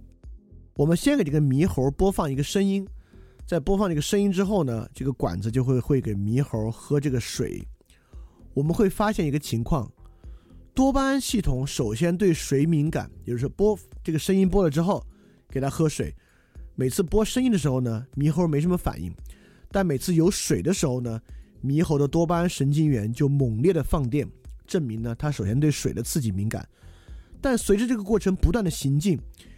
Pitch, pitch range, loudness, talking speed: 145 Hz, 115-180 Hz, -25 LUFS, 285 characters per minute